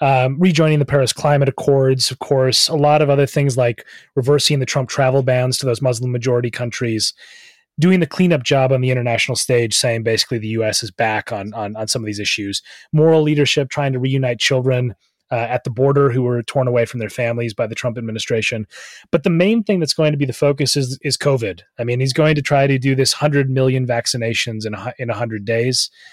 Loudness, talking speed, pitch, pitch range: -17 LUFS, 220 wpm, 130 Hz, 120-145 Hz